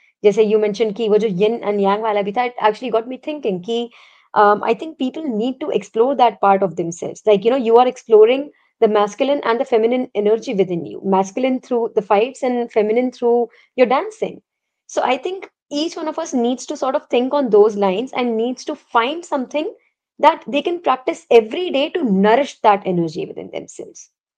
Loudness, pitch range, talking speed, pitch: -18 LUFS, 215-270 Hz, 190 wpm, 235 Hz